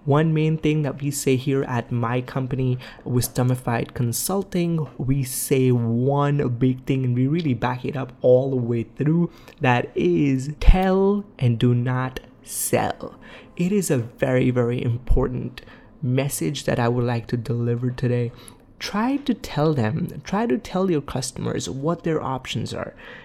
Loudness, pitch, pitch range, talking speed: -23 LUFS, 130 Hz, 125-155 Hz, 160 wpm